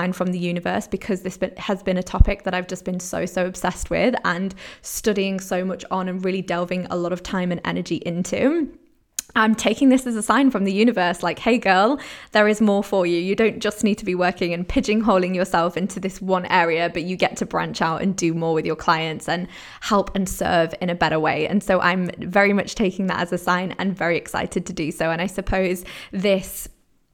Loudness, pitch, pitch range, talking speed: -21 LUFS, 185 Hz, 180-200 Hz, 230 wpm